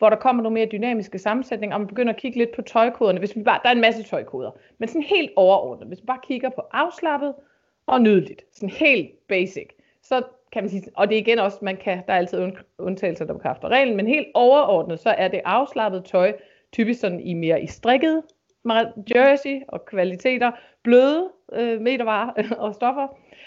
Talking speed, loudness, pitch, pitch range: 200 wpm, -21 LUFS, 230 Hz, 200-260 Hz